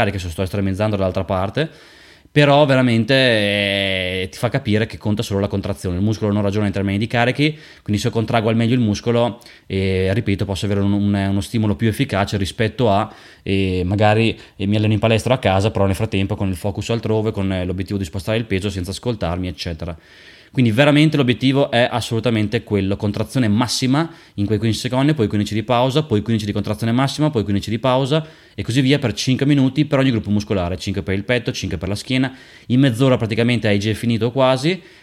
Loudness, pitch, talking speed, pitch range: -18 LUFS, 110 Hz, 205 wpm, 100-125 Hz